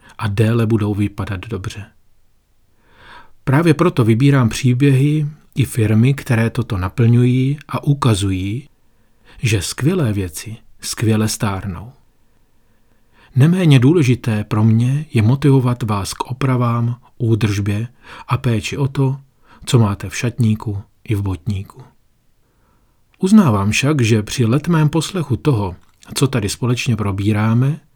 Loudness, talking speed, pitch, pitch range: -17 LUFS, 115 wpm, 115 Hz, 105-130 Hz